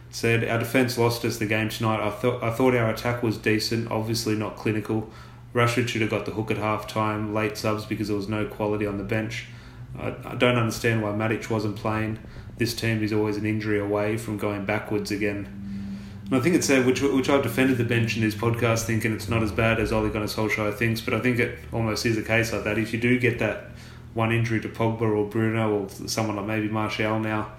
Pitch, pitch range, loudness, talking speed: 110 Hz, 105-115 Hz, -25 LUFS, 235 wpm